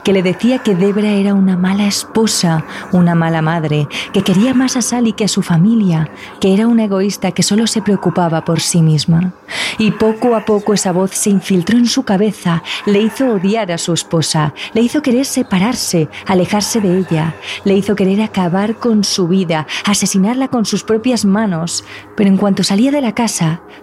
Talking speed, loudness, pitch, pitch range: 190 wpm, -14 LUFS, 200 Hz, 180-220 Hz